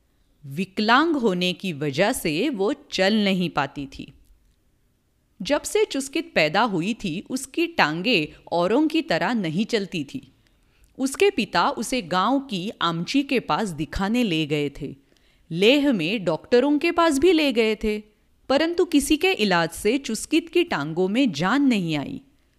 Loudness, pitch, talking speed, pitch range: -22 LUFS, 215 Hz, 150 wpm, 165-275 Hz